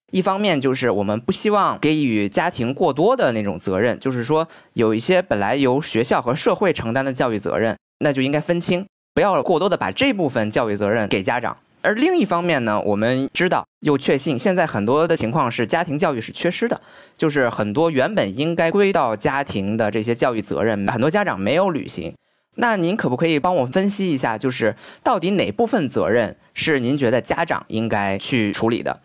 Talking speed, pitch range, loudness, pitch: 315 characters per minute, 115-180 Hz, -20 LUFS, 140 Hz